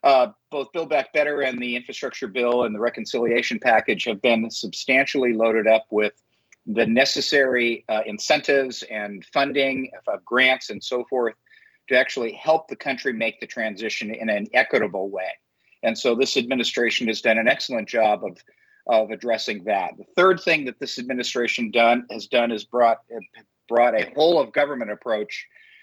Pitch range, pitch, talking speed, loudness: 115-140 Hz, 125 Hz, 170 wpm, -22 LUFS